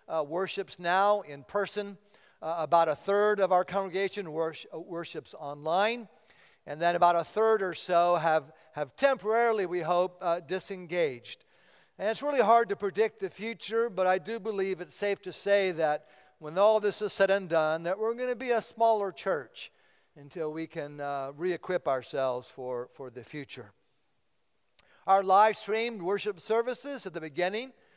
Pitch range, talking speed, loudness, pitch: 160-210 Hz, 170 wpm, -29 LUFS, 185 Hz